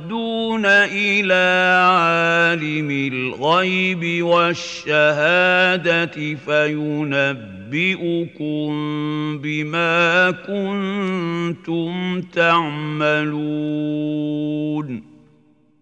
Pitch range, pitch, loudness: 150-180 Hz, 165 Hz, -18 LUFS